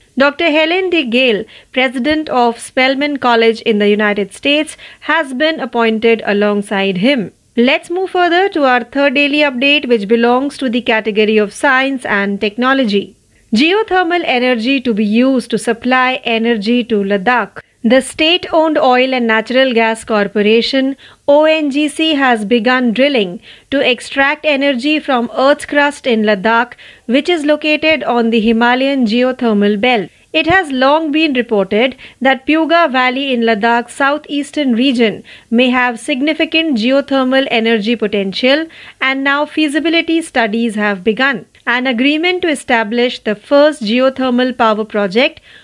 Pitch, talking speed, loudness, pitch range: 255 Hz, 140 wpm, -13 LUFS, 230-290 Hz